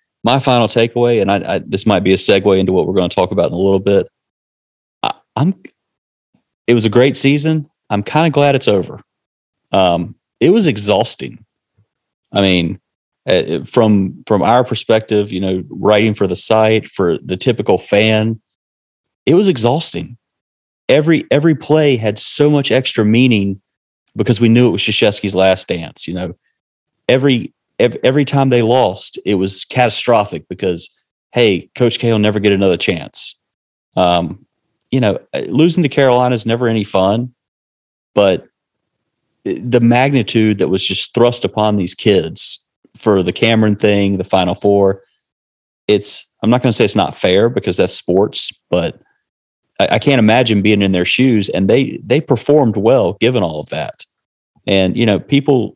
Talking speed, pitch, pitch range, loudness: 165 wpm, 110 Hz, 95-125 Hz, -14 LUFS